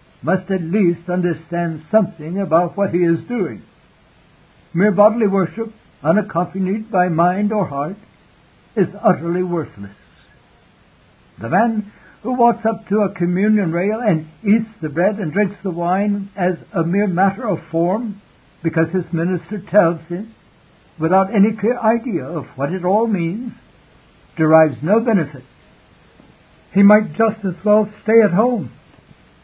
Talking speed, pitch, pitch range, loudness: 140 wpm, 190 Hz, 170-210 Hz, -18 LUFS